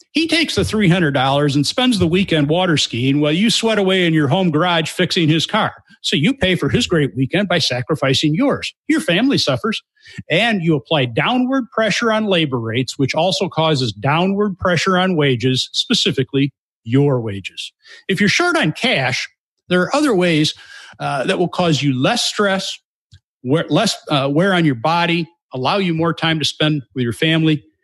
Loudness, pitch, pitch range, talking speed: -16 LUFS, 165 Hz, 140-195 Hz, 180 wpm